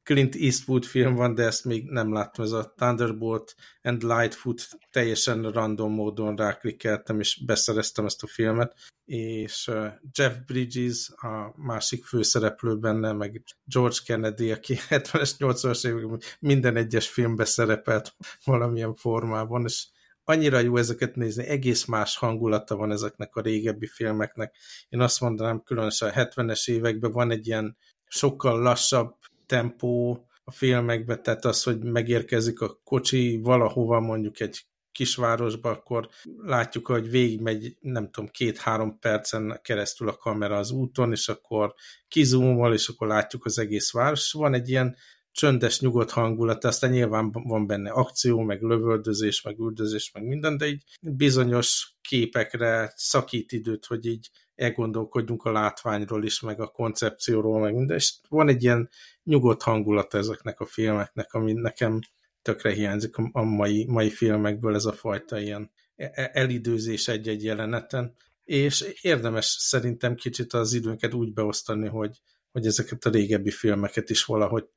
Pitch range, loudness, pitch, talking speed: 110-125 Hz, -26 LUFS, 115 Hz, 140 wpm